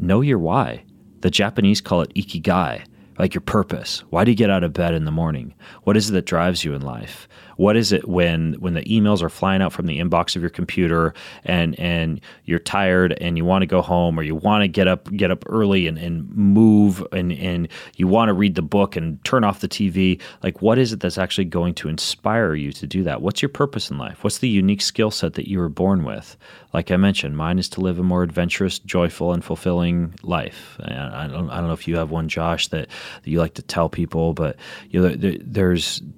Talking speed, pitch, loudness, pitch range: 240 wpm, 90 Hz, -20 LUFS, 85-100 Hz